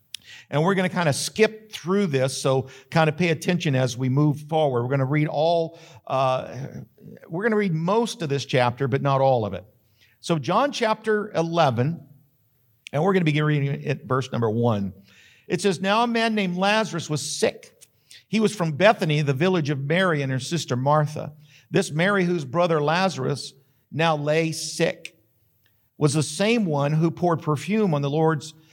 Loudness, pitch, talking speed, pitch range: -23 LUFS, 155 Hz, 190 wpm, 135-180 Hz